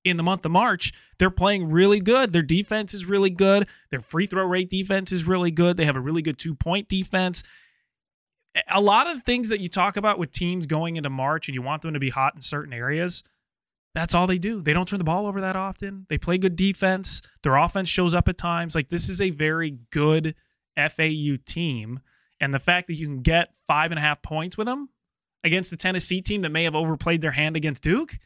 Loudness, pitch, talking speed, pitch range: -23 LUFS, 175 Hz, 235 wpm, 155-190 Hz